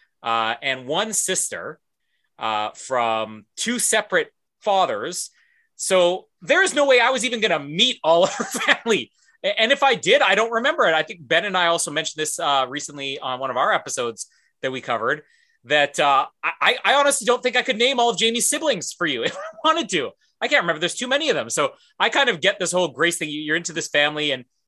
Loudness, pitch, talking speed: -20 LUFS, 195 Hz, 220 wpm